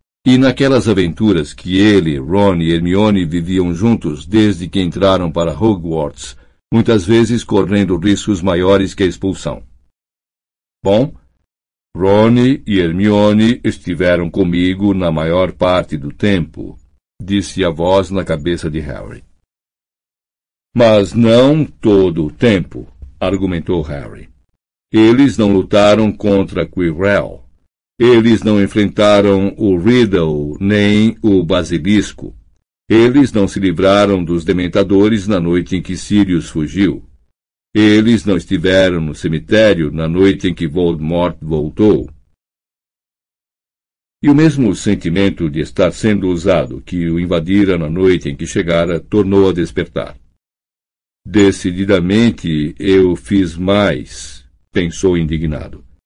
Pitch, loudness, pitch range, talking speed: 95 Hz, -13 LUFS, 80-100 Hz, 115 wpm